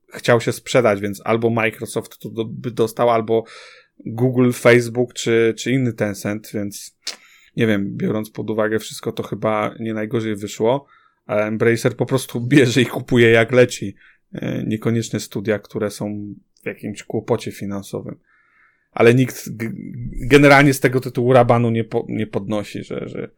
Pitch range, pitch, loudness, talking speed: 110-125 Hz, 115 Hz, -19 LUFS, 150 wpm